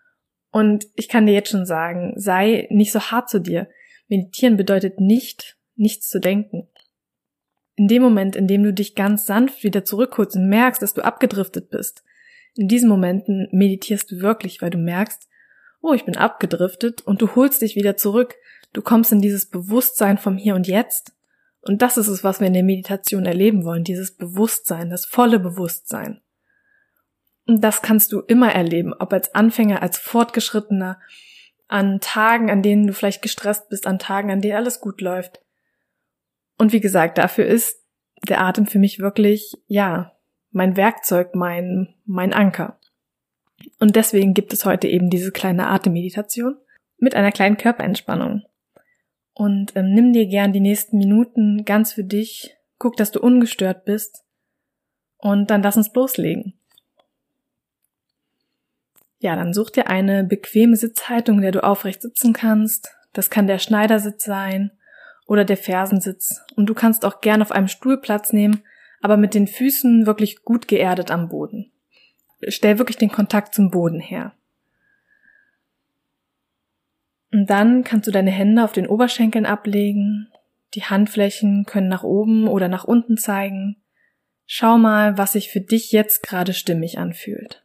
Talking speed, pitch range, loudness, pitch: 160 wpm, 195-225 Hz, -18 LUFS, 210 Hz